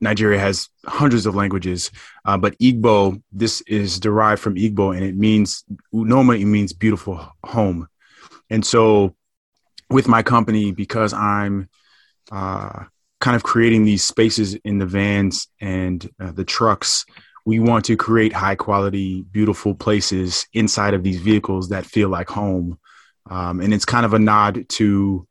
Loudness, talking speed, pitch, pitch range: -18 LUFS, 155 wpm, 100 Hz, 95-110 Hz